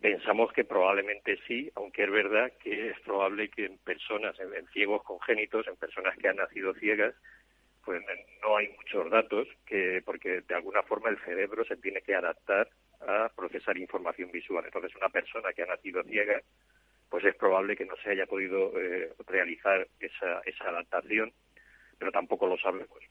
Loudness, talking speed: -31 LUFS, 170 wpm